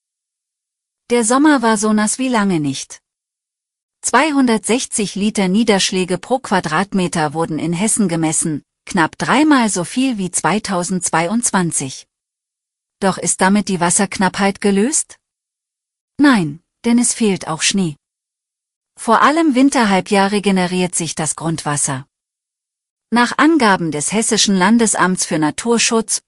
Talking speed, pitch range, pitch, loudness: 110 wpm, 170-230 Hz, 195 Hz, -15 LUFS